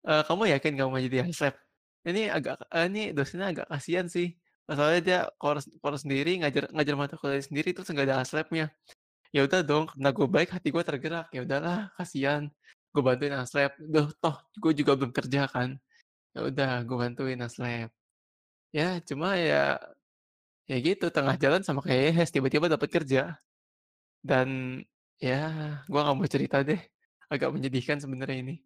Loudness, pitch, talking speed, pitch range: -29 LUFS, 145 Hz, 165 wpm, 135-165 Hz